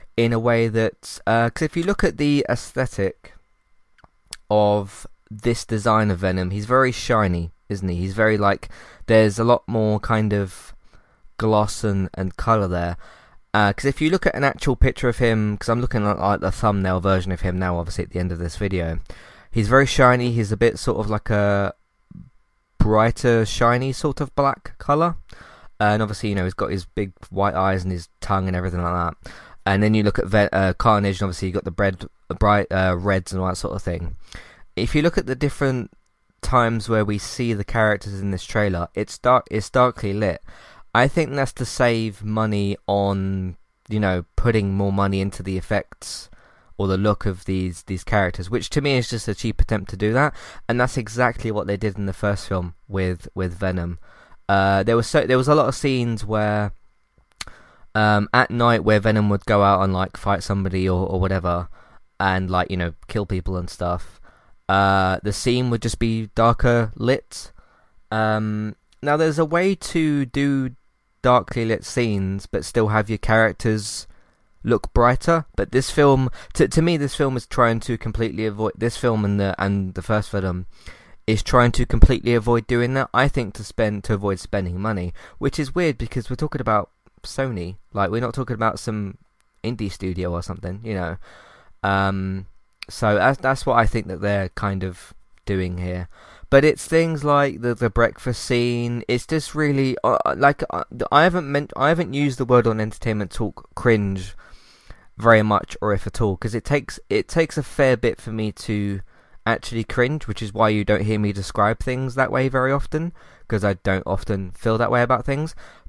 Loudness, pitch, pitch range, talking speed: -21 LUFS, 110 Hz, 95-120 Hz, 200 wpm